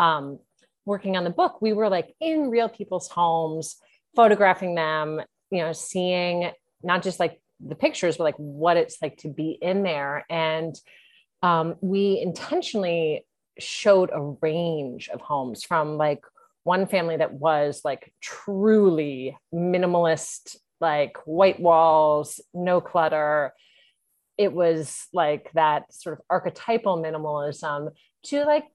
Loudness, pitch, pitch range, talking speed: -24 LUFS, 170 Hz, 155-190 Hz, 135 wpm